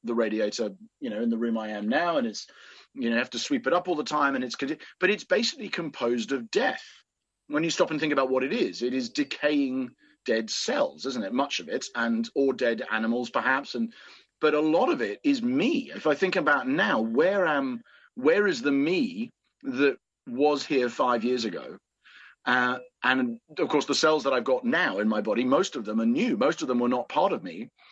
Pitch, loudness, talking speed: 145 Hz, -26 LUFS, 230 wpm